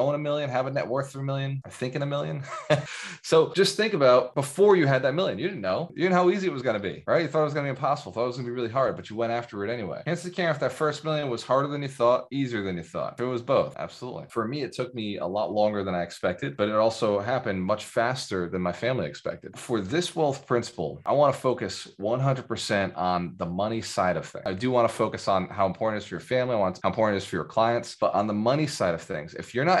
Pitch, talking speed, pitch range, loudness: 125 Hz, 300 wpm, 105-145 Hz, -26 LUFS